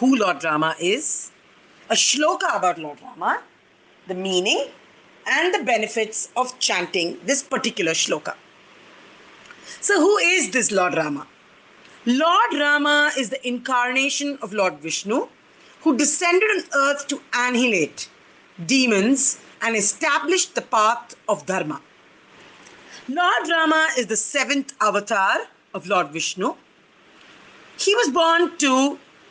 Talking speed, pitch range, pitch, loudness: 120 wpm, 210-300 Hz, 255 Hz, -20 LUFS